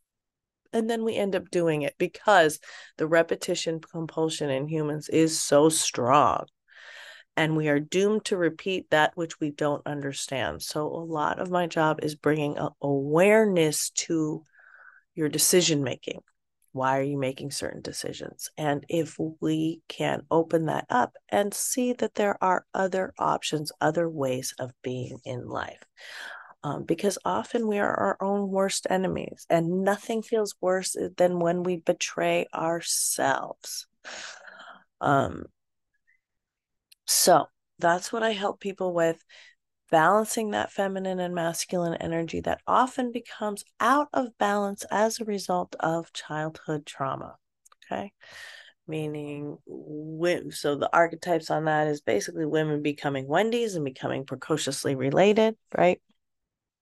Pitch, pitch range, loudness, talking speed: 165 Hz, 155-195 Hz, -26 LUFS, 135 wpm